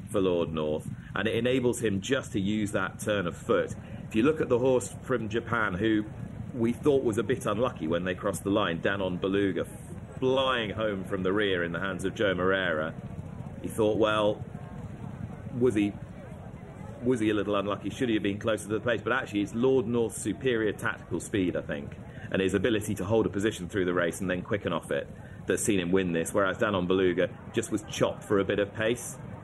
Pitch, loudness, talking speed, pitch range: 105 Hz, -29 LUFS, 215 wpm, 95-115 Hz